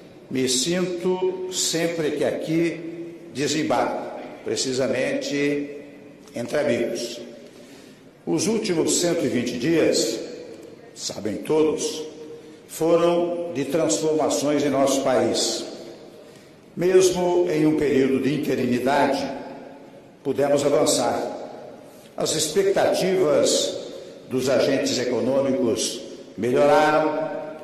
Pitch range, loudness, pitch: 145-175 Hz, -22 LUFS, 155 Hz